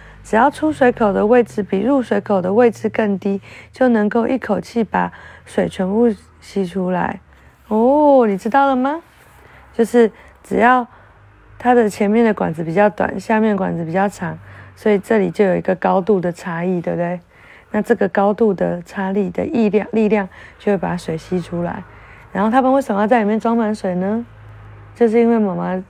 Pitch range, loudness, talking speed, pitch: 180-230 Hz, -17 LUFS, 265 characters per minute, 205 Hz